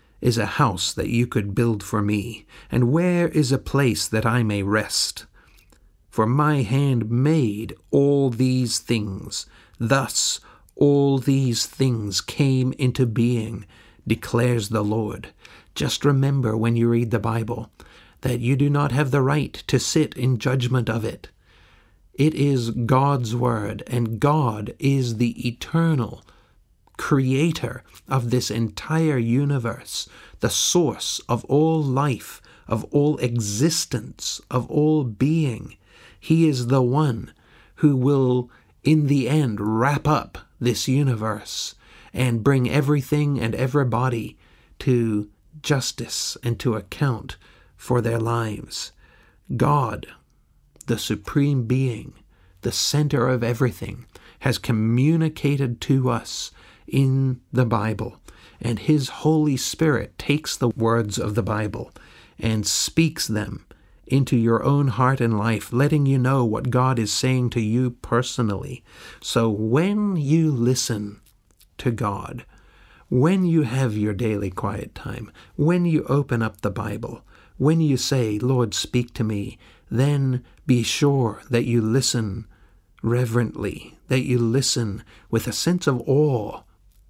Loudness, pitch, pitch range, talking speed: -22 LUFS, 120 Hz, 110-135 Hz, 130 wpm